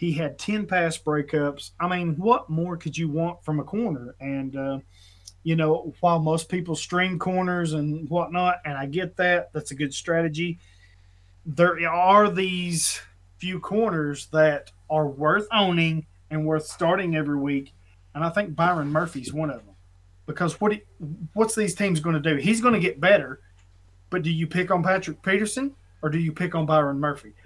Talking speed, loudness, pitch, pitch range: 185 wpm, -24 LUFS, 160 Hz, 145-180 Hz